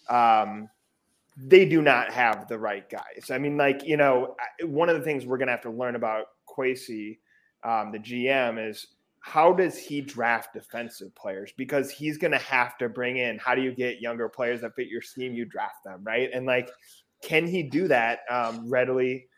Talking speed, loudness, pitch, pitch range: 200 wpm, -25 LUFS, 125 Hz, 115-140 Hz